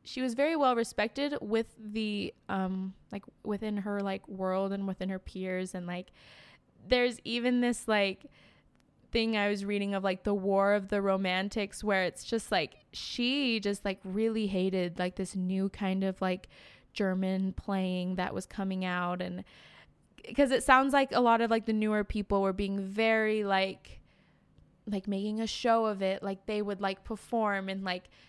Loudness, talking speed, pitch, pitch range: -31 LUFS, 180 wpm, 200 Hz, 190-225 Hz